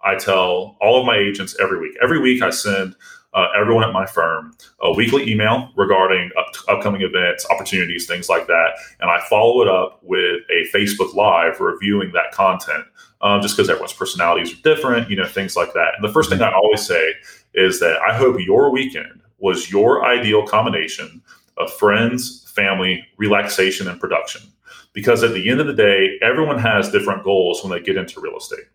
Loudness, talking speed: -17 LUFS, 190 wpm